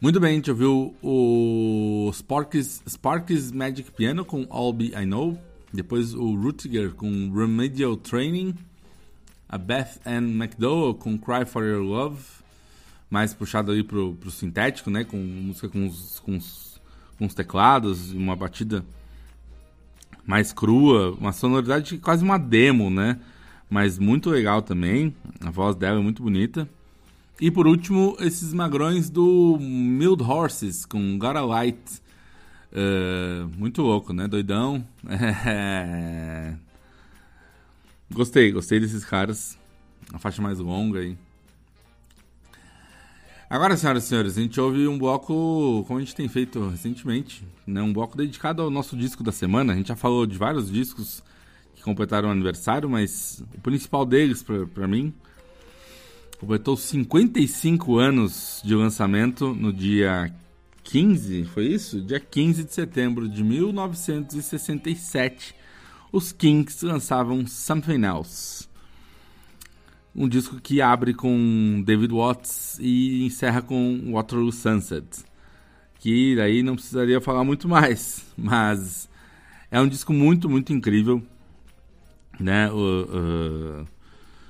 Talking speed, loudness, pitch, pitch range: 130 wpm, -23 LUFS, 115 Hz, 95-135 Hz